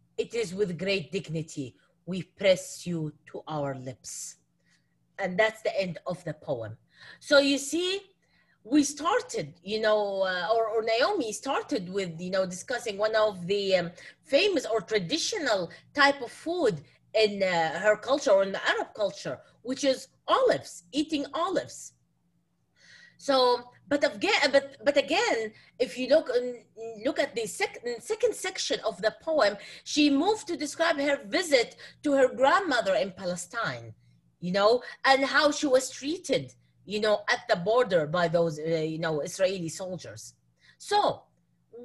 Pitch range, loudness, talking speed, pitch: 180-285 Hz, -27 LUFS, 145 wpm, 220 Hz